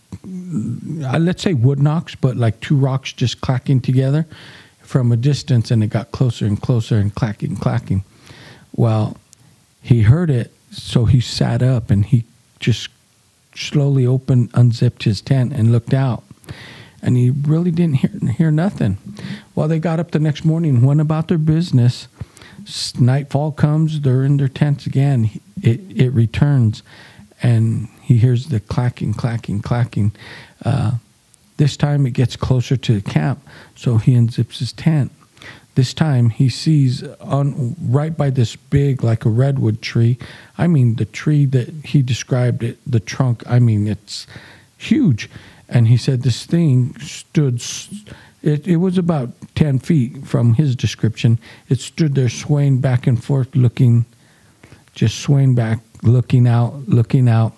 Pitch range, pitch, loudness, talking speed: 115-145 Hz, 130 Hz, -17 LUFS, 155 wpm